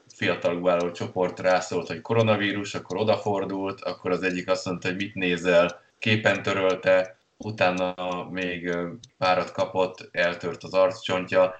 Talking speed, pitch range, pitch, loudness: 130 wpm, 90-95 Hz, 95 Hz, -25 LUFS